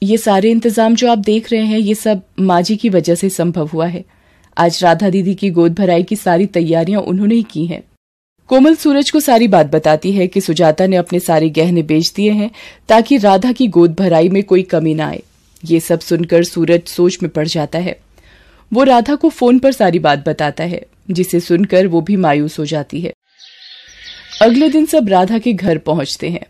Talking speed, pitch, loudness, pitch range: 205 wpm, 185 Hz, -13 LUFS, 165-225 Hz